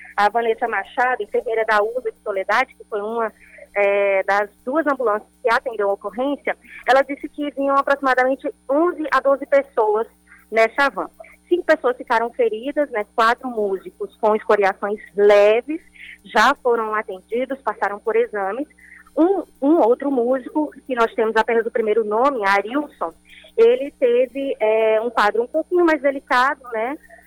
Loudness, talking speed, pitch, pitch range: -20 LUFS, 150 wpm, 240 Hz, 215-280 Hz